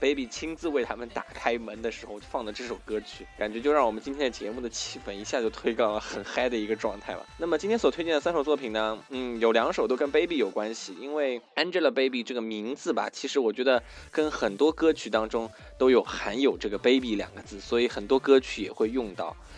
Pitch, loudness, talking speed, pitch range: 120 Hz, -28 LUFS, 390 characters per minute, 110-145 Hz